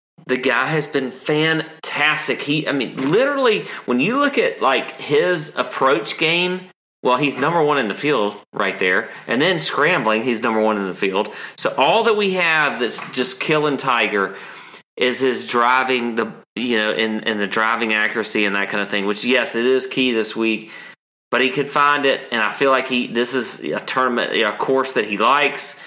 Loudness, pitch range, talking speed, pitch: -18 LUFS, 110-150 Hz, 200 wpm, 130 Hz